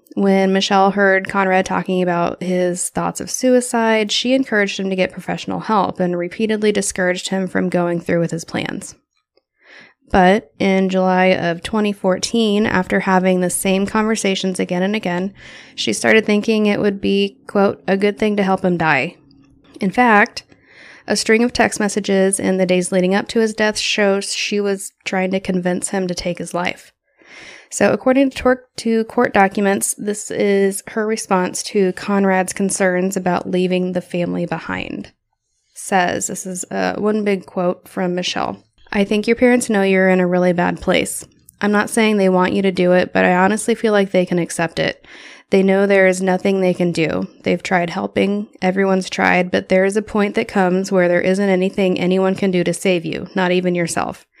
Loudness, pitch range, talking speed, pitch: -17 LUFS, 180-210 Hz, 185 wpm, 195 Hz